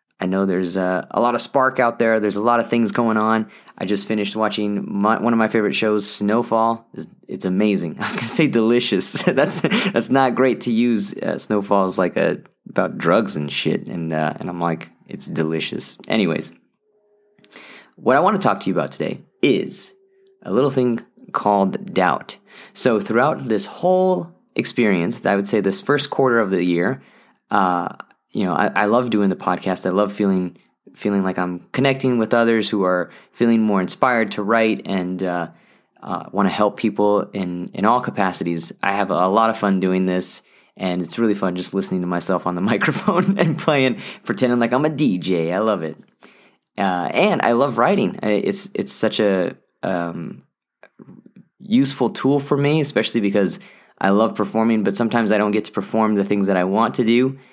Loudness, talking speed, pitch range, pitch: -19 LUFS, 195 wpm, 95-120 Hz, 105 Hz